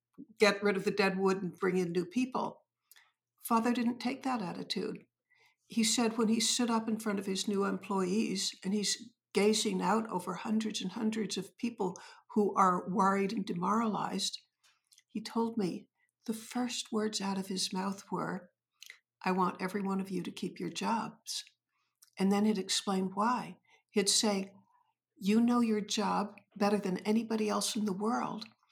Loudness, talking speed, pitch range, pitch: -33 LUFS, 170 wpm, 195-230 Hz, 205 Hz